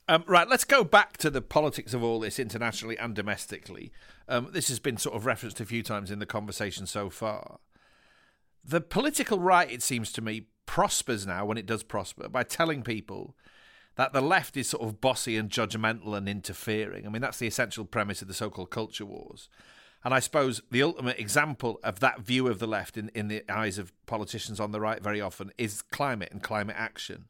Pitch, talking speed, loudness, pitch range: 115 Hz, 210 wpm, -29 LUFS, 105-130 Hz